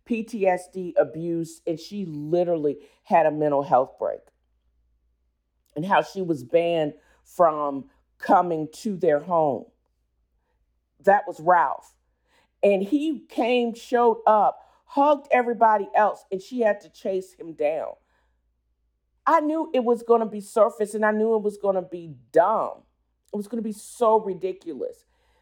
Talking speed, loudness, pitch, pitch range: 145 wpm, -23 LUFS, 180 Hz, 145-220 Hz